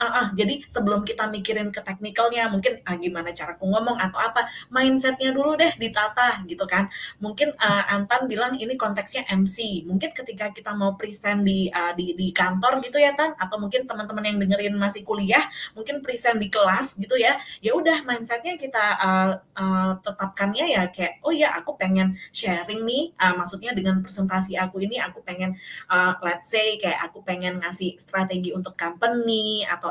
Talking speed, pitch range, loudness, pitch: 180 wpm, 185-235 Hz, -23 LUFS, 205 Hz